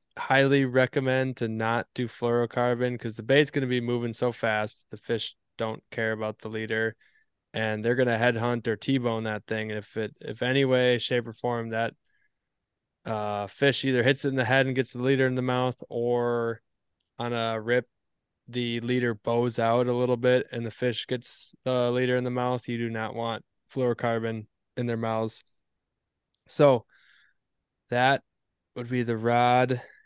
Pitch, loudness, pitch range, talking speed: 120 Hz, -27 LUFS, 115-125 Hz, 180 wpm